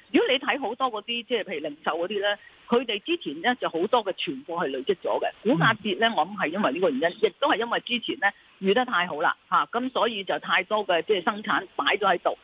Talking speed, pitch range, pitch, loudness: 365 characters per minute, 200-330 Hz, 240 Hz, -25 LUFS